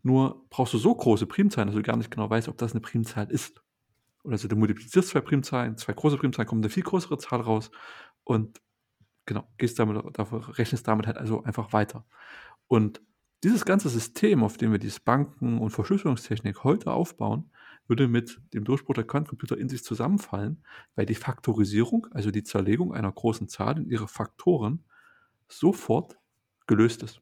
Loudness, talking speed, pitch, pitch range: -27 LUFS, 175 wpm, 115 Hz, 110-140 Hz